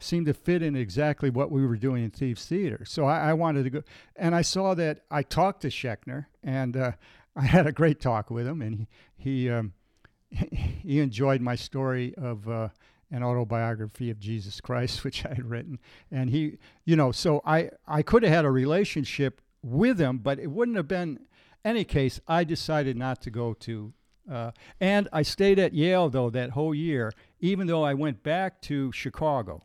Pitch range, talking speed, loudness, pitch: 120-160 Hz, 200 wpm, -27 LUFS, 140 Hz